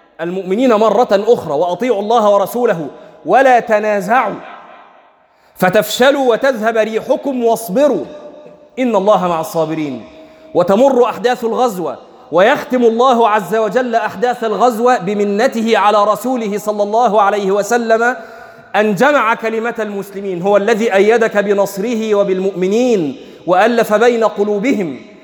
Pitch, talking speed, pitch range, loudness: 225 Hz, 105 wpm, 205-245 Hz, -13 LUFS